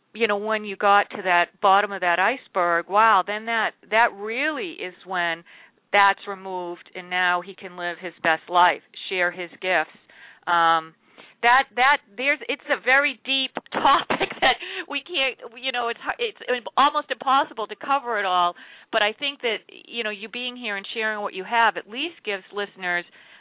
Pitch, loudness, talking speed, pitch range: 215 Hz, -23 LUFS, 180 wpm, 185-260 Hz